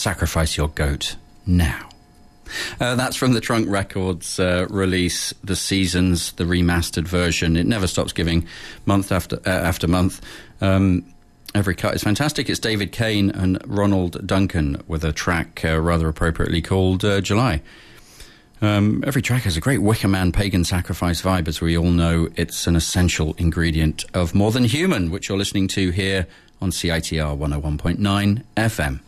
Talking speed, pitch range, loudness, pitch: 160 wpm, 85-100 Hz, -20 LUFS, 90 Hz